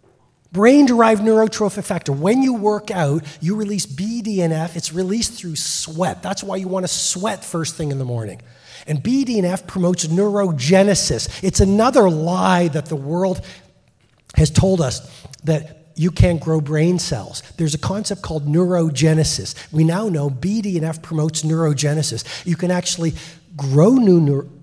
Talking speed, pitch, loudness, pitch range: 150 wpm, 165 Hz, -18 LUFS, 155-195 Hz